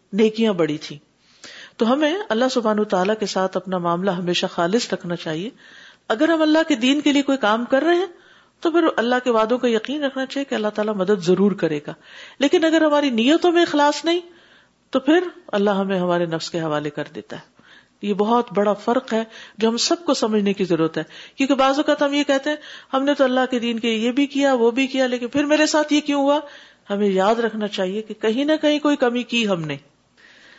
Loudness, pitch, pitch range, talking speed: -20 LUFS, 235 Hz, 200-290 Hz, 225 wpm